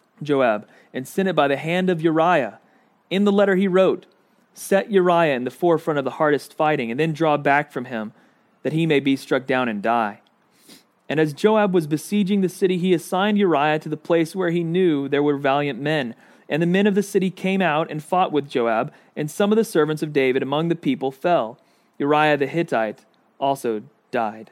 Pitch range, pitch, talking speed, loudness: 140-185 Hz, 160 Hz, 210 wpm, -21 LUFS